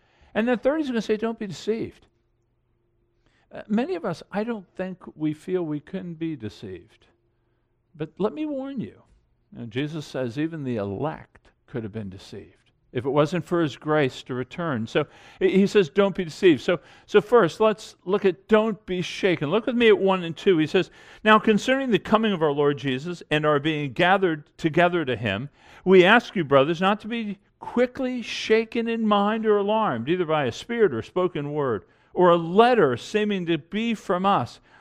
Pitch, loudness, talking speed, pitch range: 175 Hz, -23 LUFS, 200 wpm, 145-215 Hz